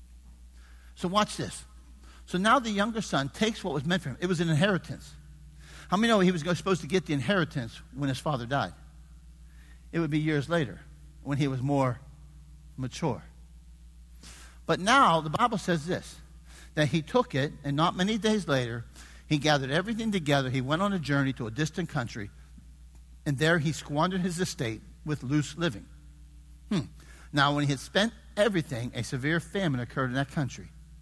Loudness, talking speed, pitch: -28 LUFS, 185 wpm, 140 Hz